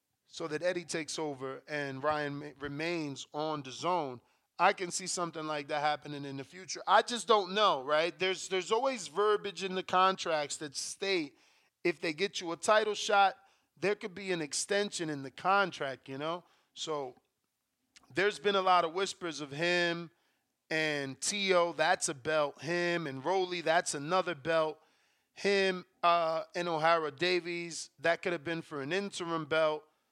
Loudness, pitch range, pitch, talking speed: -32 LUFS, 150-190 Hz, 170 Hz, 170 wpm